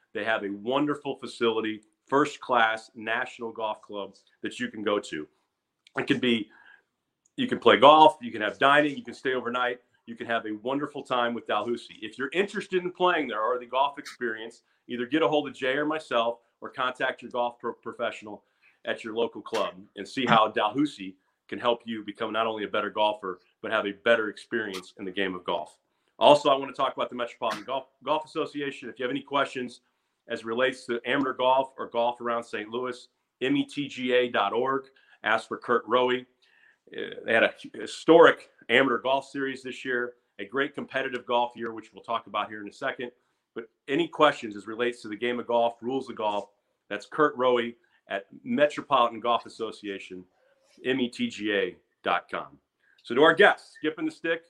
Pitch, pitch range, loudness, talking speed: 120 Hz, 110-135 Hz, -27 LUFS, 190 wpm